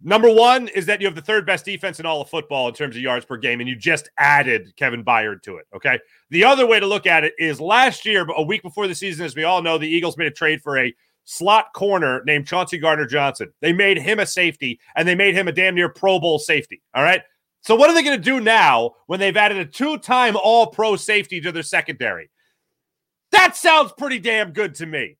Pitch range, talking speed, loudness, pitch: 160-215 Hz, 250 wpm, -17 LUFS, 185 Hz